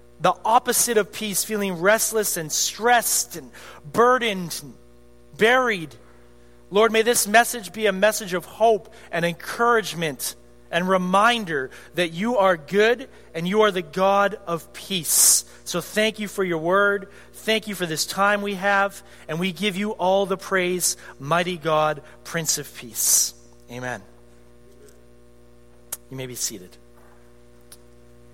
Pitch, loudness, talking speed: 180 Hz, -21 LUFS, 140 wpm